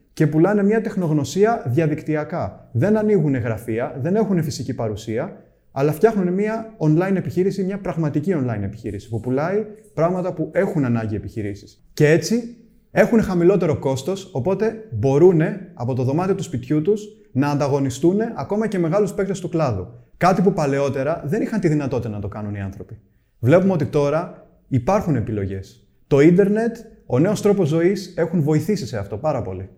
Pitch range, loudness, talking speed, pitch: 130-195 Hz, -20 LUFS, 155 wpm, 160 Hz